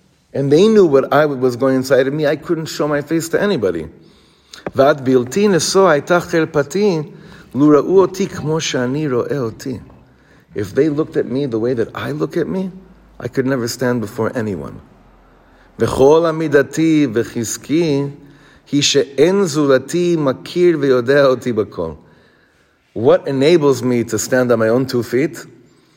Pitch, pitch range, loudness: 145 Hz, 130-165 Hz, -15 LUFS